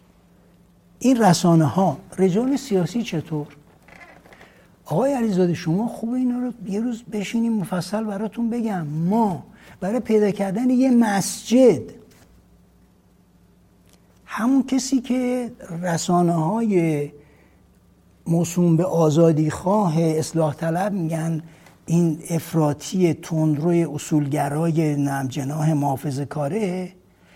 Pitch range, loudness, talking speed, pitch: 155-215 Hz, -21 LUFS, 95 wpm, 175 Hz